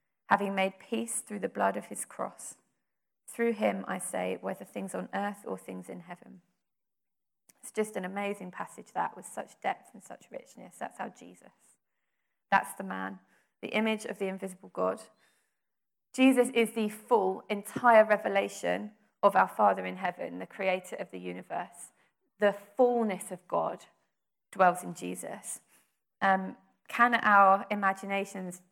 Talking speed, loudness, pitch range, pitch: 150 wpm, -30 LUFS, 180-215 Hz, 195 Hz